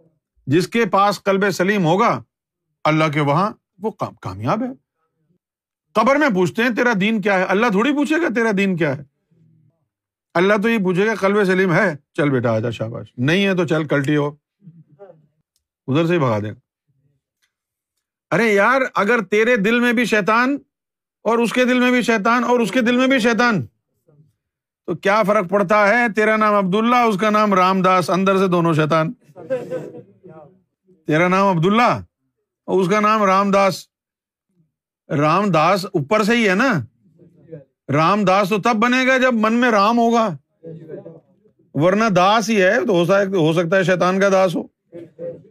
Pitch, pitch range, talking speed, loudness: 190 Hz, 155-215 Hz, 170 wpm, -17 LUFS